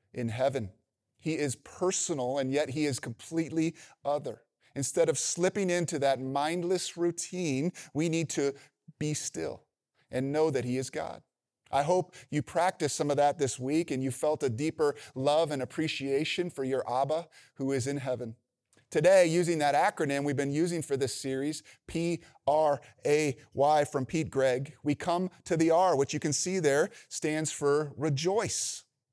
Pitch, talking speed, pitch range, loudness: 150 Hz, 170 wpm, 135-165 Hz, -30 LUFS